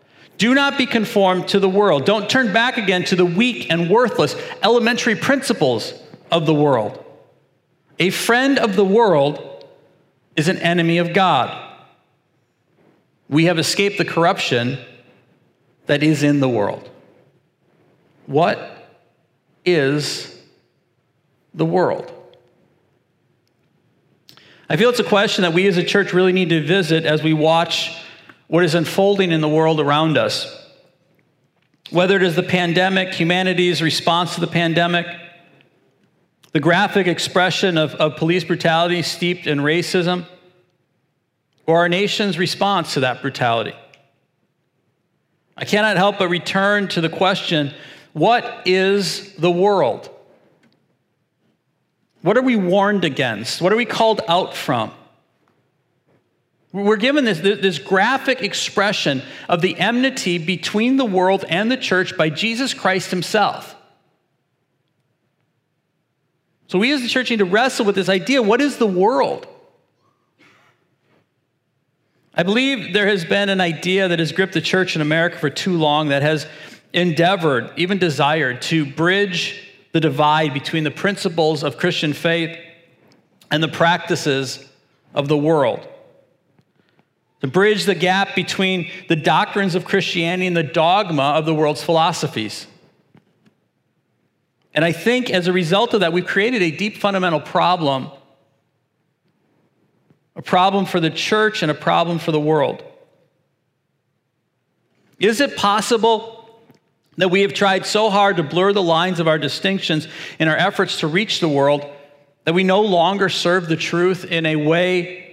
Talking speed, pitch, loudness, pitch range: 140 wpm, 175 Hz, -17 LUFS, 160-200 Hz